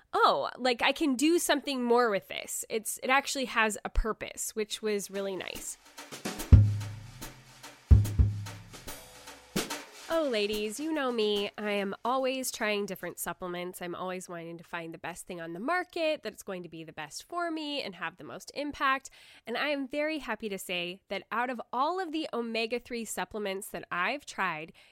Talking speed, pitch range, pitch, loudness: 180 wpm, 175-265 Hz, 215 Hz, -31 LUFS